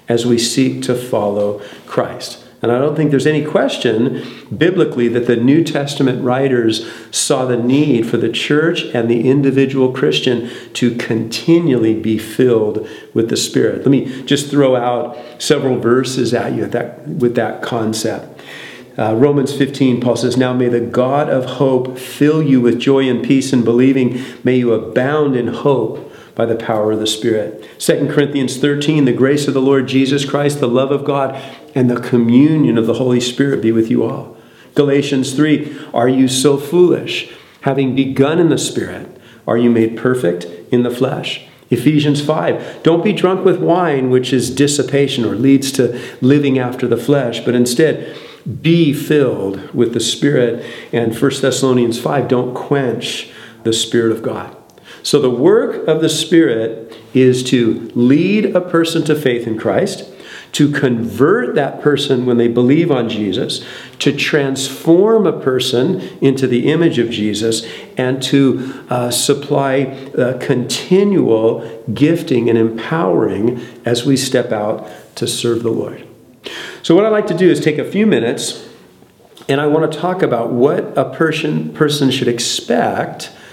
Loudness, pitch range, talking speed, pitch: -15 LUFS, 120-145 Hz, 165 wpm, 130 Hz